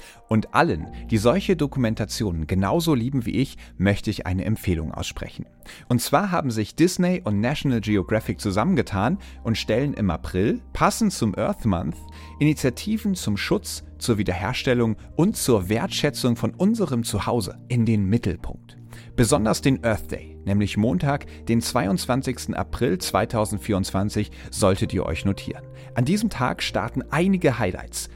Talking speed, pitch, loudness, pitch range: 140 wpm, 115 Hz, -23 LUFS, 100-130 Hz